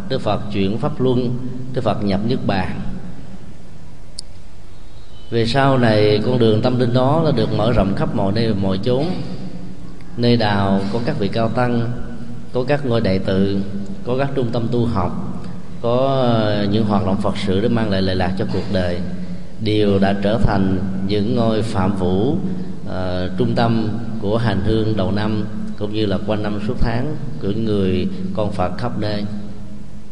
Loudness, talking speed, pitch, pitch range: -19 LUFS, 175 wpm, 105 Hz, 100-120 Hz